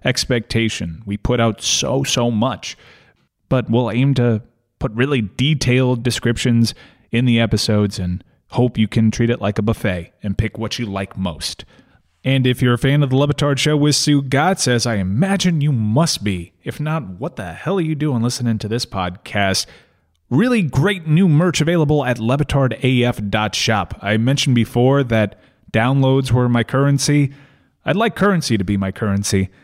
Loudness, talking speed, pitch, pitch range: -18 LUFS, 170 wpm, 120 Hz, 110-140 Hz